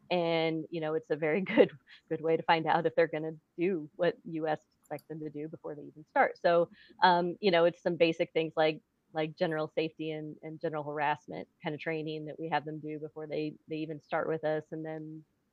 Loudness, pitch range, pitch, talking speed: -32 LUFS, 155-165 Hz, 160 Hz, 230 wpm